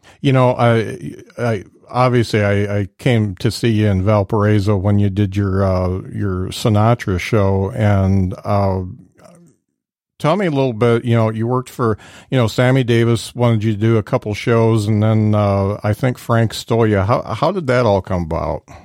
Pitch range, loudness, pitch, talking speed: 100-120 Hz, -16 LUFS, 110 Hz, 190 wpm